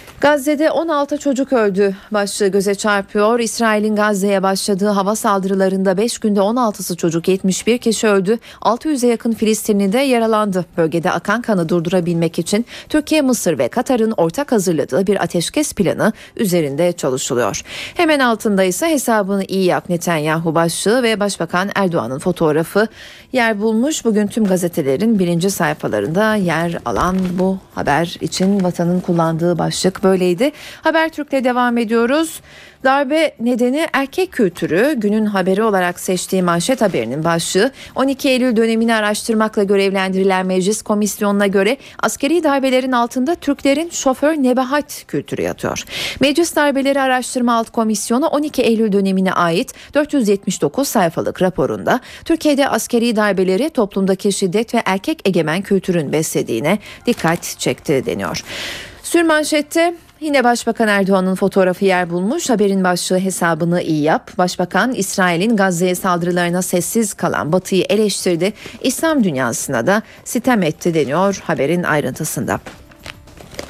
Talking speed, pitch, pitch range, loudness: 125 wpm, 205 Hz, 180-245 Hz, -16 LUFS